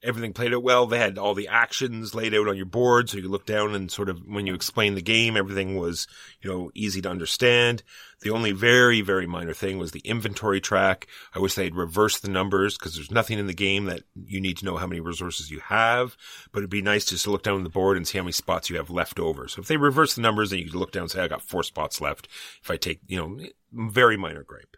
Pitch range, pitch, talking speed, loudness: 95-115 Hz, 100 Hz, 270 wpm, -24 LUFS